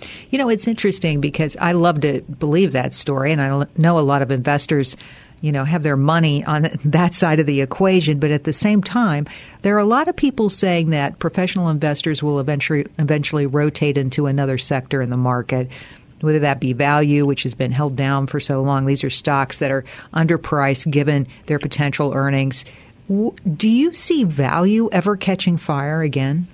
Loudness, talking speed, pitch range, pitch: -18 LUFS, 190 wpm, 140-175 Hz, 150 Hz